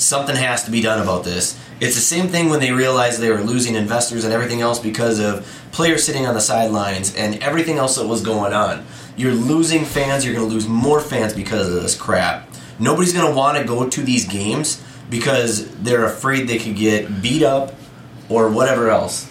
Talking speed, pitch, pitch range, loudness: 210 wpm, 120 Hz, 110-135 Hz, -17 LUFS